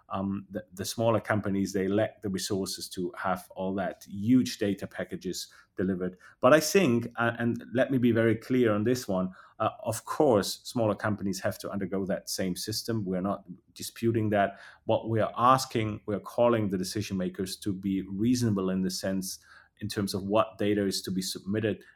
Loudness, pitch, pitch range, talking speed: -29 LUFS, 100 Hz, 95-115 Hz, 190 wpm